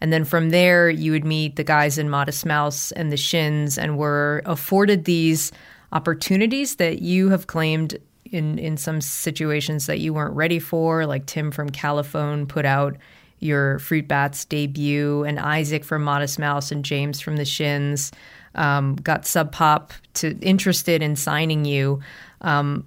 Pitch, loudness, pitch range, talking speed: 150 Hz, -21 LUFS, 145-165 Hz, 165 wpm